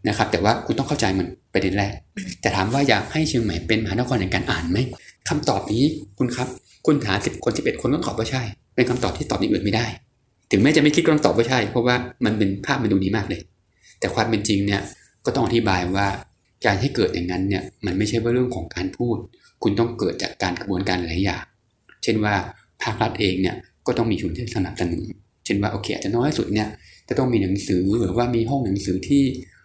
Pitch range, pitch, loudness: 95-120 Hz, 110 Hz, -22 LUFS